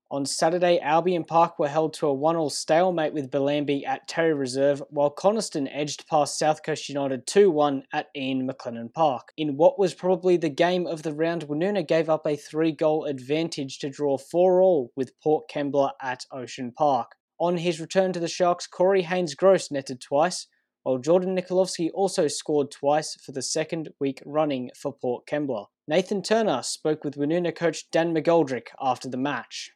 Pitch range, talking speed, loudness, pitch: 140-170 Hz, 175 wpm, -25 LUFS, 155 Hz